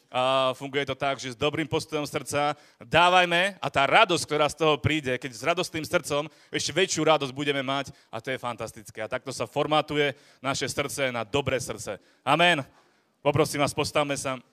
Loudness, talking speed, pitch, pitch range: -25 LUFS, 180 wpm, 145 Hz, 135-155 Hz